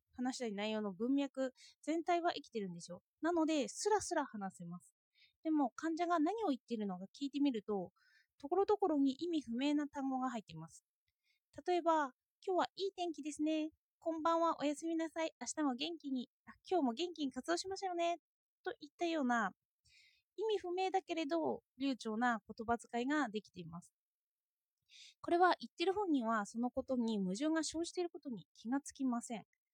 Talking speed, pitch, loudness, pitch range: 355 characters per minute, 290 Hz, -39 LUFS, 235-340 Hz